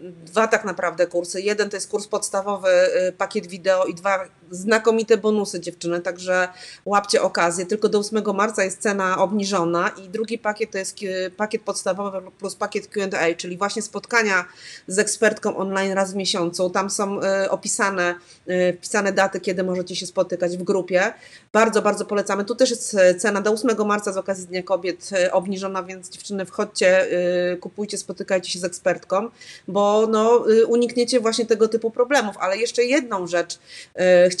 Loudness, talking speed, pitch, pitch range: -21 LUFS, 160 wpm, 195 Hz, 185-210 Hz